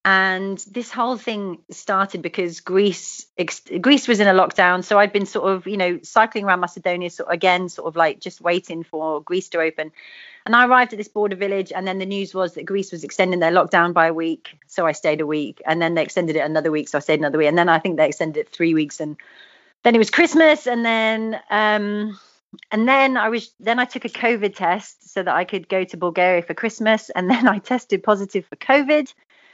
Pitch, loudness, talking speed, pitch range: 190 Hz, -19 LUFS, 235 wpm, 170-220 Hz